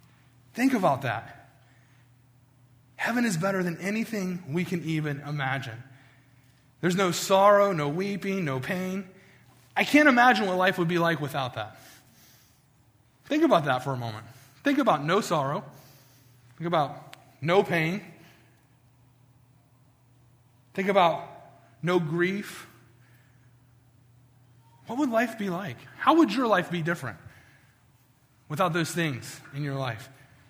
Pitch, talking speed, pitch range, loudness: 135 Hz, 125 wpm, 125-180 Hz, -26 LUFS